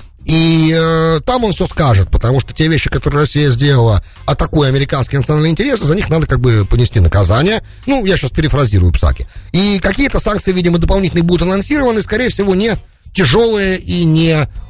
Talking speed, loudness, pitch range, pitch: 170 wpm, -12 LUFS, 130-190 Hz, 160 Hz